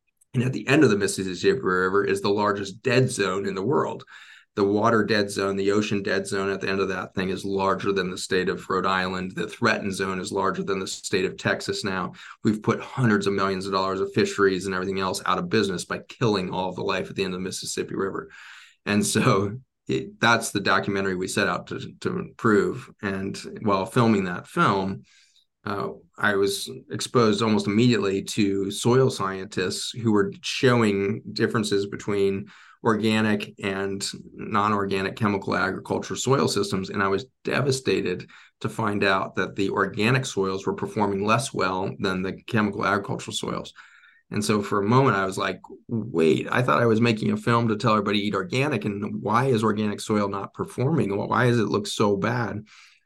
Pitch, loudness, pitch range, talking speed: 100 Hz, -24 LUFS, 95-110 Hz, 190 wpm